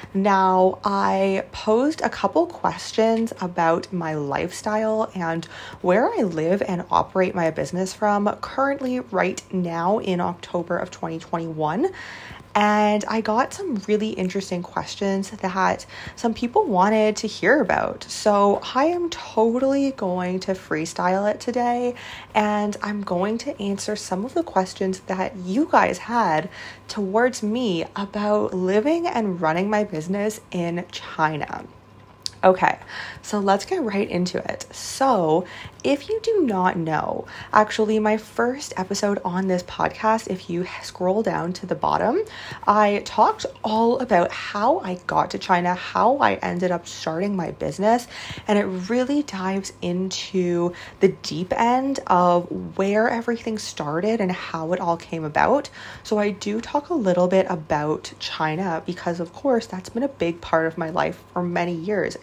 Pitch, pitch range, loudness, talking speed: 195 Hz, 180-225 Hz, -23 LUFS, 150 wpm